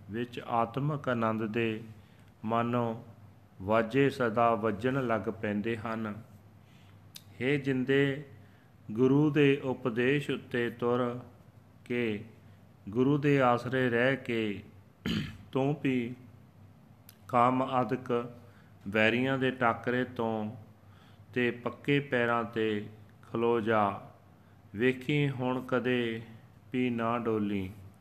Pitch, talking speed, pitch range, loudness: 120 Hz, 95 wpm, 110-125 Hz, -30 LUFS